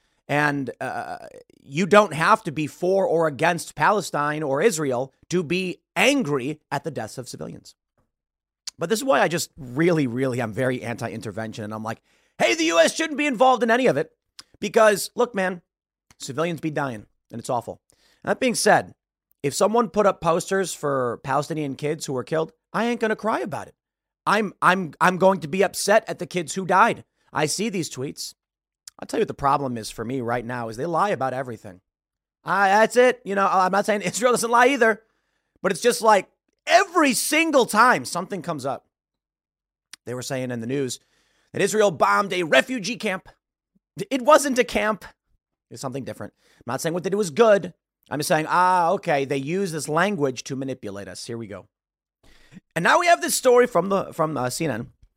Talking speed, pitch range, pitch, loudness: 195 wpm, 135-215 Hz, 175 Hz, -22 LUFS